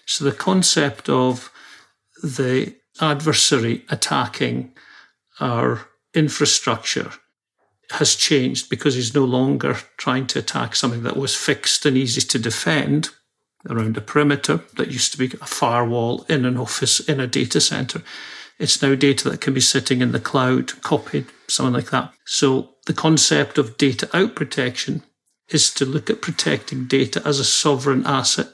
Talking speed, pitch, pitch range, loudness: 155 wpm, 135 Hz, 125-150 Hz, -19 LUFS